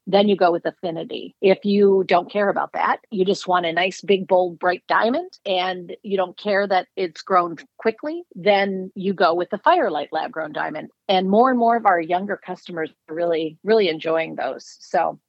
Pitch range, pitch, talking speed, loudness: 180-205 Hz, 190 Hz, 200 wpm, -21 LUFS